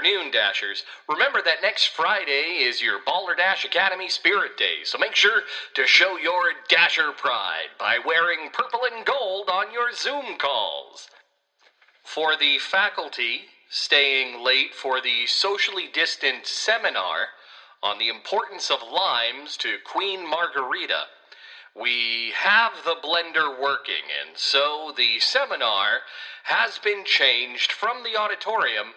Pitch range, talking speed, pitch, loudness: 155-245 Hz, 135 wpm, 195 Hz, -22 LUFS